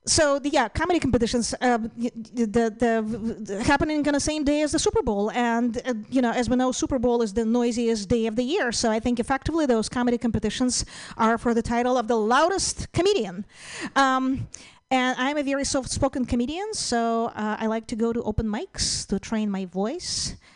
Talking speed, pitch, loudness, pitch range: 205 wpm, 245 Hz, -24 LUFS, 230-275 Hz